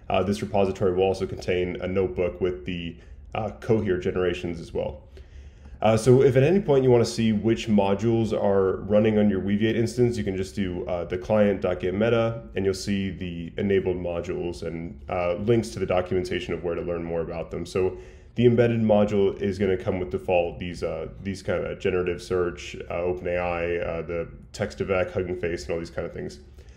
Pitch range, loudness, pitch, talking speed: 85-105 Hz, -25 LUFS, 95 Hz, 200 wpm